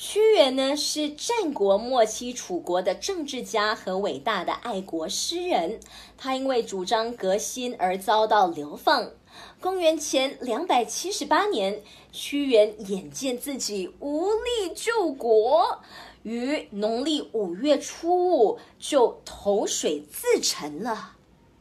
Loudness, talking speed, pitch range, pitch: -25 LUFS, 185 characters per minute, 210-320 Hz, 250 Hz